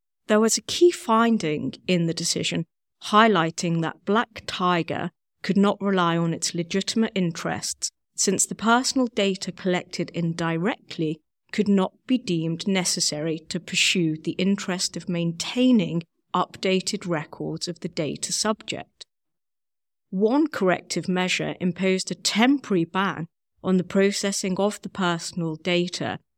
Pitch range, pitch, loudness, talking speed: 170-200 Hz, 185 Hz, -24 LUFS, 125 wpm